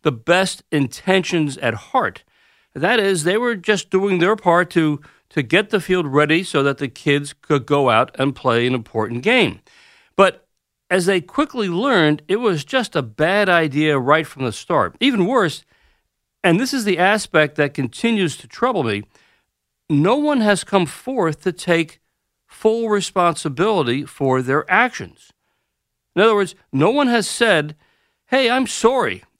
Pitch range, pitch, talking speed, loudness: 145-200 Hz, 170 Hz, 165 wpm, -18 LUFS